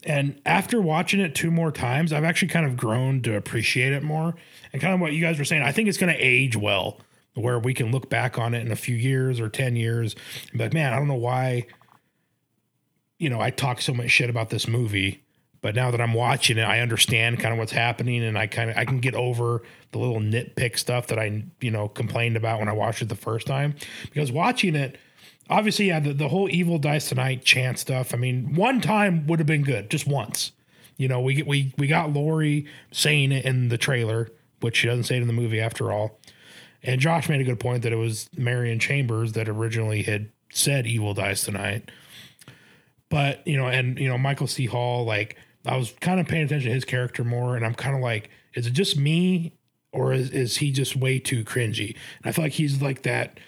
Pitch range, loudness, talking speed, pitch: 115-145 Hz, -24 LUFS, 230 wpm, 125 Hz